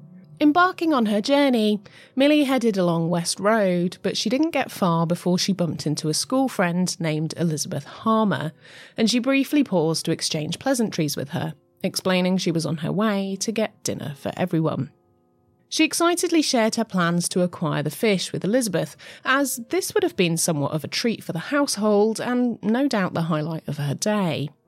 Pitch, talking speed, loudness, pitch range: 190 Hz, 180 wpm, -22 LUFS, 165-245 Hz